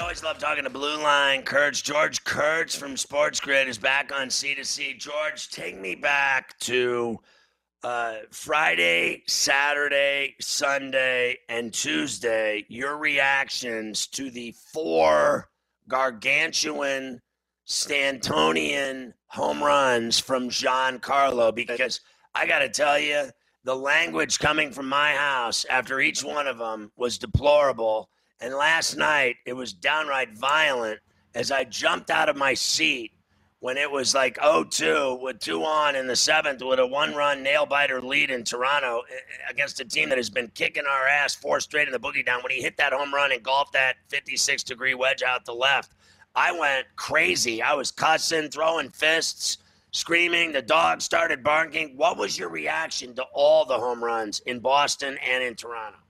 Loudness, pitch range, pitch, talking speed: -23 LUFS, 125-145 Hz, 135 Hz, 160 wpm